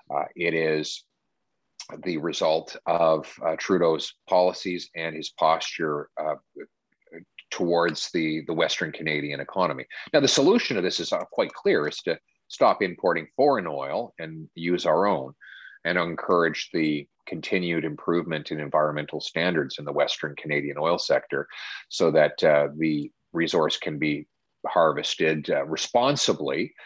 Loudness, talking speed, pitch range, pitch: -25 LUFS, 135 wpm, 75-85 Hz, 80 Hz